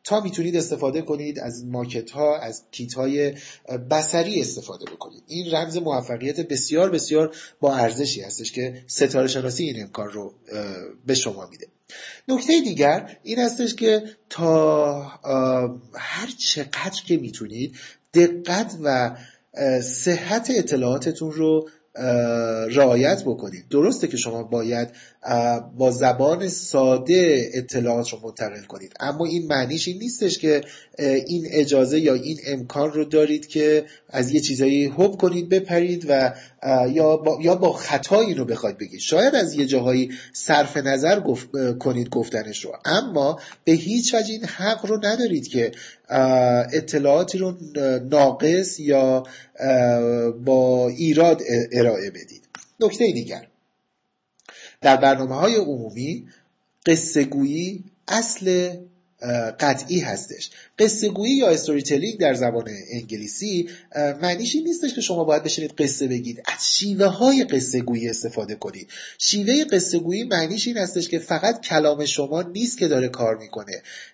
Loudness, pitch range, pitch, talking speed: -21 LUFS, 125-175 Hz, 145 Hz, 130 wpm